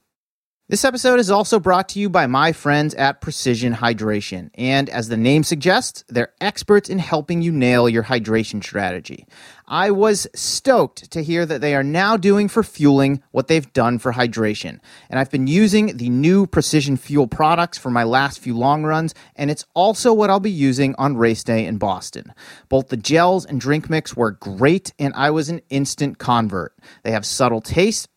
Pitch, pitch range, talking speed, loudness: 145 Hz, 125-180 Hz, 190 wpm, -18 LUFS